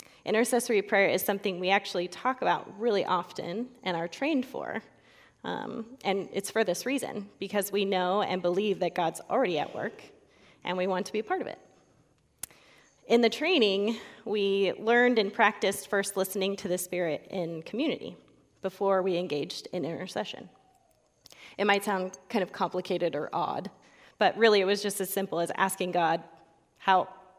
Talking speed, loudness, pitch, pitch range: 170 wpm, -29 LUFS, 195 Hz, 185-210 Hz